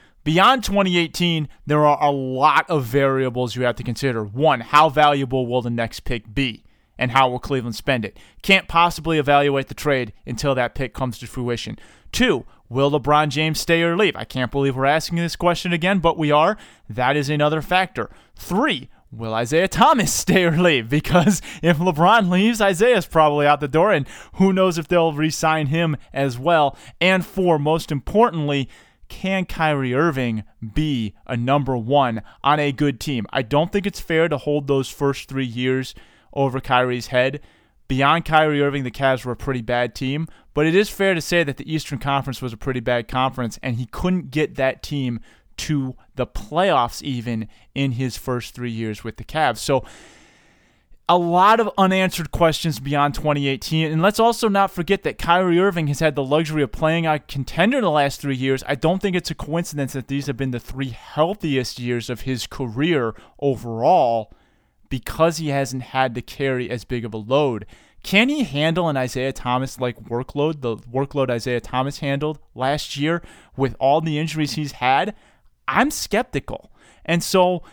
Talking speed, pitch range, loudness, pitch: 185 wpm, 125-165 Hz, -20 LUFS, 140 Hz